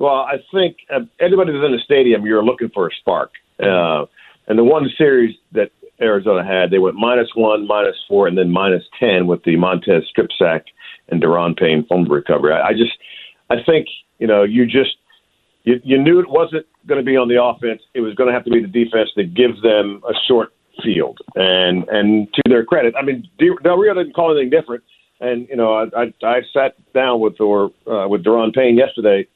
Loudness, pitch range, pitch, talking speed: -15 LUFS, 105-135 Hz, 120 Hz, 215 wpm